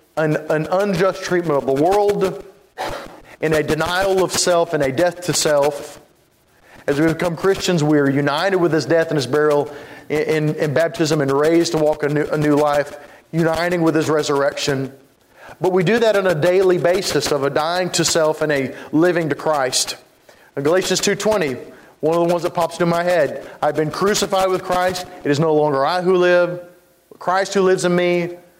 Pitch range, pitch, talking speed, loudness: 150-180 Hz, 165 Hz, 195 wpm, -18 LUFS